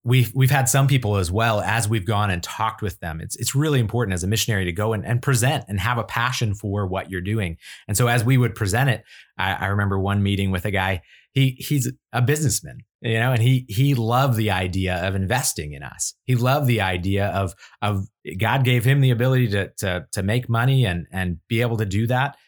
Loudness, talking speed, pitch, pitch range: -22 LUFS, 235 wpm, 115 Hz, 100-125 Hz